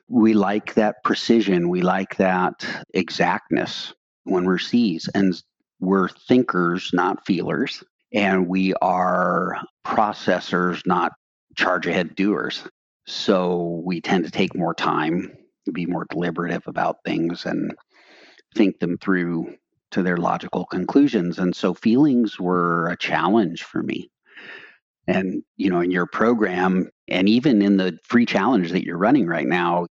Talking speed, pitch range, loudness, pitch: 140 wpm, 85-100 Hz, -21 LUFS, 90 Hz